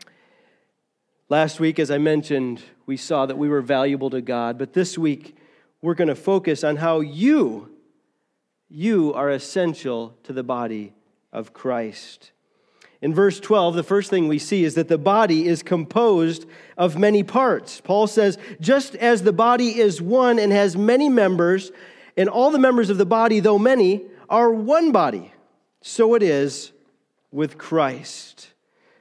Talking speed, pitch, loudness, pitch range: 160 wpm, 170 Hz, -20 LUFS, 145-215 Hz